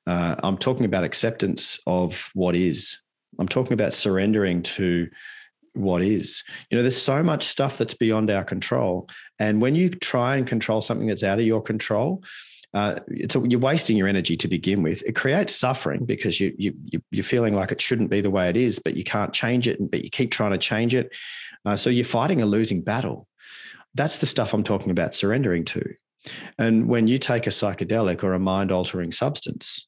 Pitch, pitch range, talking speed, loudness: 110 Hz, 95-120 Hz, 200 wpm, -23 LUFS